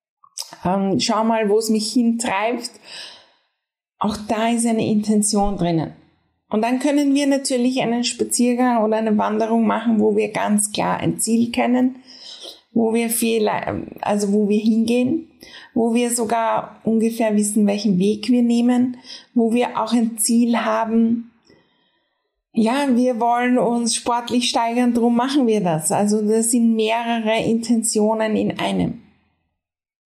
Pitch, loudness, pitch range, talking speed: 230 Hz, -19 LUFS, 220-245 Hz, 140 wpm